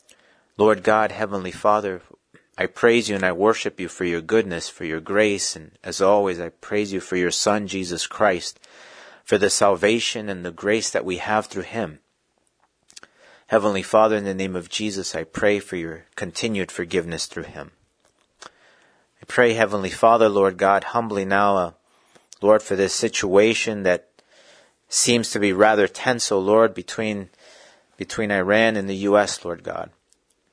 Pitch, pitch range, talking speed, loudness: 100 Hz, 95-110 Hz, 165 wpm, -21 LUFS